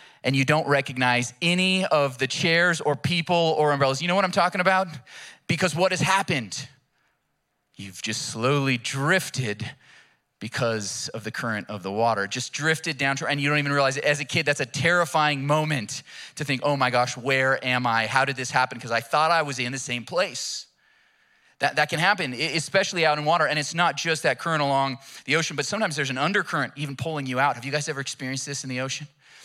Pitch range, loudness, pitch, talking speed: 130-165 Hz, -24 LUFS, 145 Hz, 215 wpm